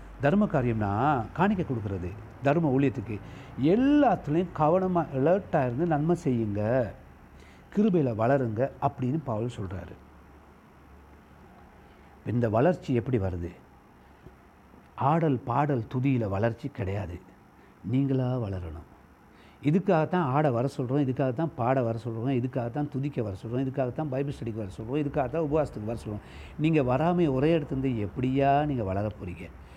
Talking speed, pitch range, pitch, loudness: 115 wpm, 100-145 Hz, 130 Hz, -27 LUFS